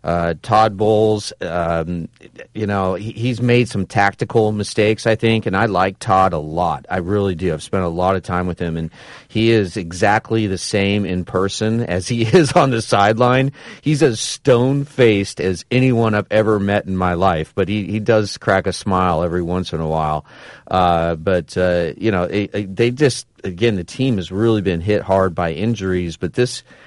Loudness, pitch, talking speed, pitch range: -18 LUFS, 100 Hz, 200 wpm, 90-115 Hz